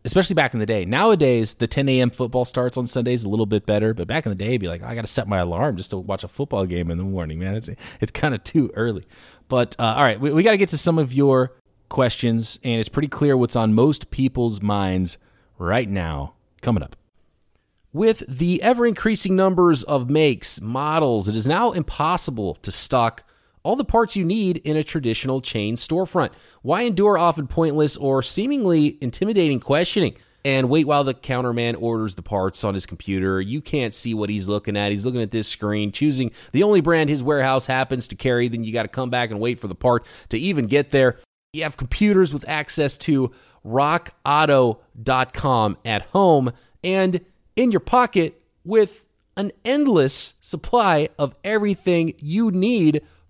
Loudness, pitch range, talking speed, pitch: -21 LUFS, 110-160 Hz, 195 wpm, 130 Hz